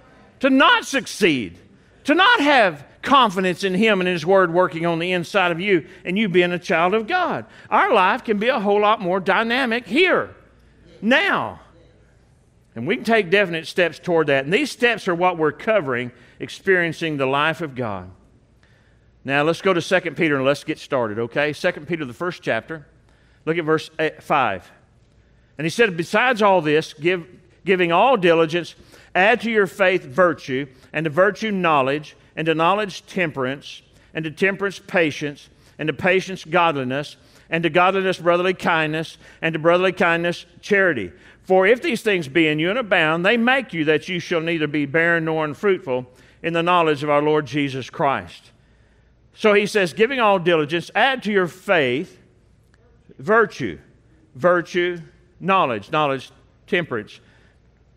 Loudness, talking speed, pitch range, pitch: -19 LUFS, 165 wpm, 150-195 Hz, 170 Hz